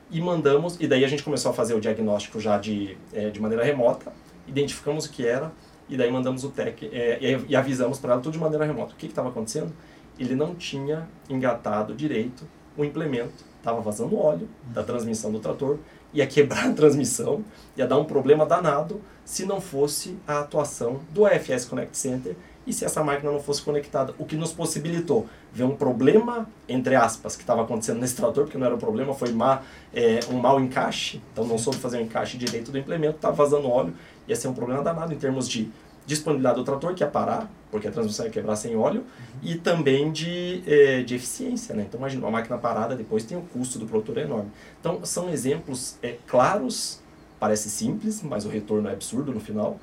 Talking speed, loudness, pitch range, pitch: 210 wpm, -25 LUFS, 120-155 Hz, 140 Hz